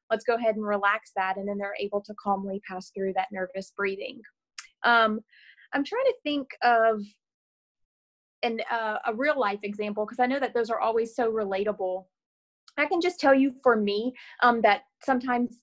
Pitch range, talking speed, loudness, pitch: 200-250 Hz, 185 wpm, -27 LUFS, 225 Hz